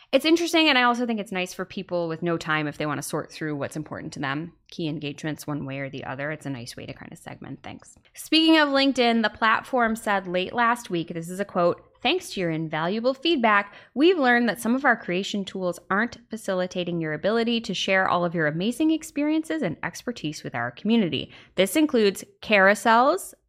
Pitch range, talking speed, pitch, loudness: 165-240 Hz, 215 wpm, 195 Hz, -24 LUFS